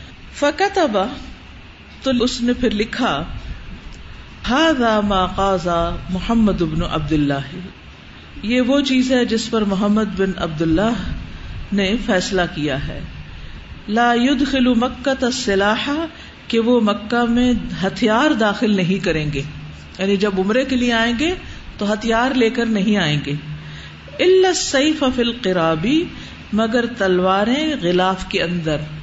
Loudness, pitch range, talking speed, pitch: -18 LUFS, 175-245 Hz, 130 wpm, 210 Hz